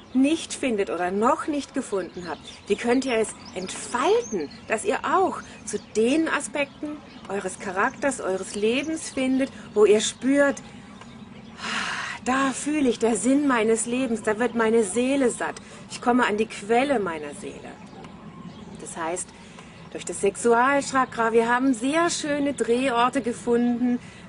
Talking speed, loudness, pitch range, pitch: 140 wpm, -24 LUFS, 210-265 Hz, 235 Hz